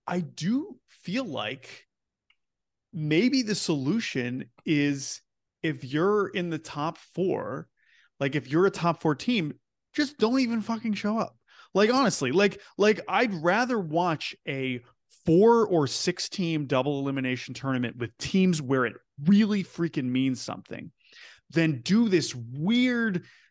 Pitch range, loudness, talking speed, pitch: 140-210 Hz, -27 LUFS, 140 wpm, 170 Hz